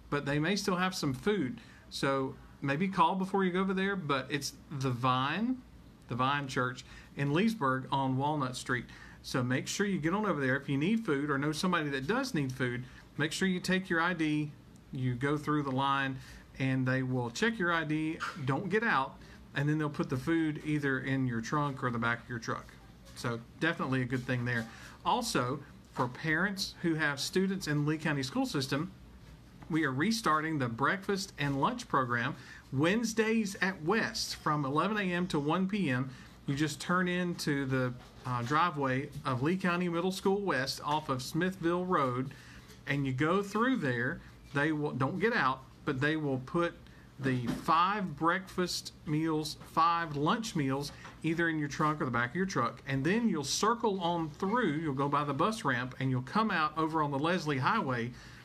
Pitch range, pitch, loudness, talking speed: 135-175 Hz, 150 Hz, -32 LUFS, 190 wpm